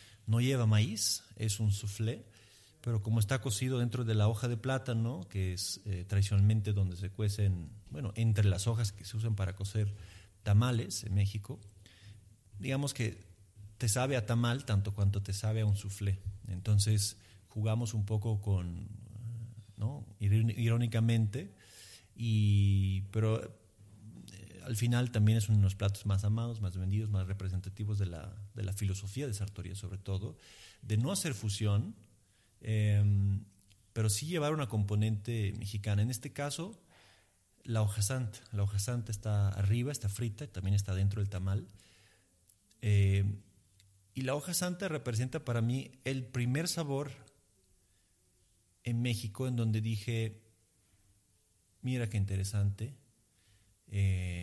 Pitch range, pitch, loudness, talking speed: 100-115 Hz, 105 Hz, -34 LUFS, 140 wpm